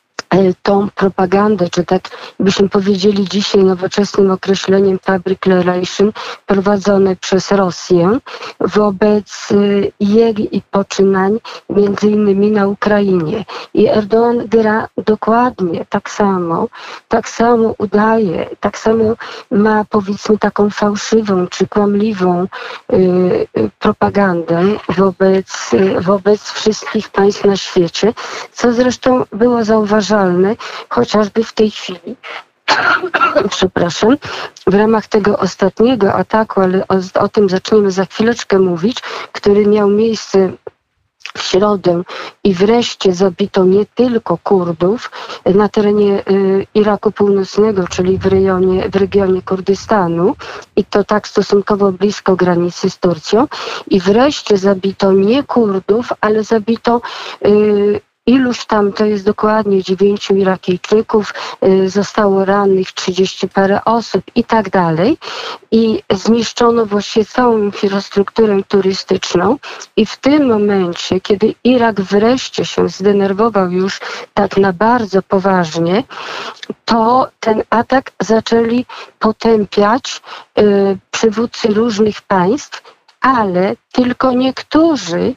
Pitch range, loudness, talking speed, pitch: 195-220 Hz, -13 LUFS, 110 wpm, 205 Hz